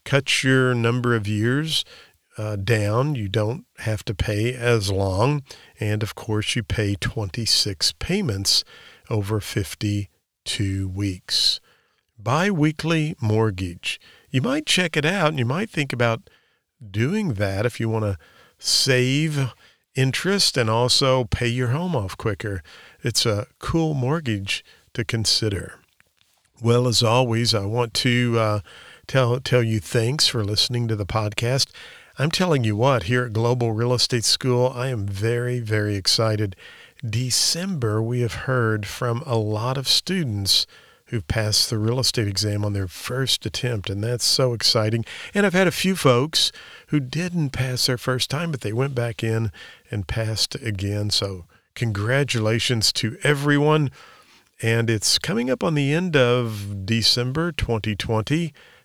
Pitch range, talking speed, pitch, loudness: 110-130 Hz, 150 wpm, 120 Hz, -22 LUFS